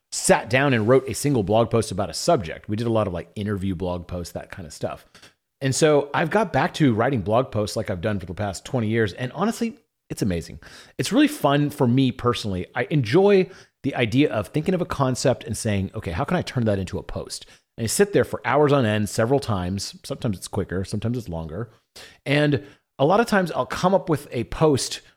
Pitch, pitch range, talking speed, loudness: 120 Hz, 105-145 Hz, 235 wpm, -23 LUFS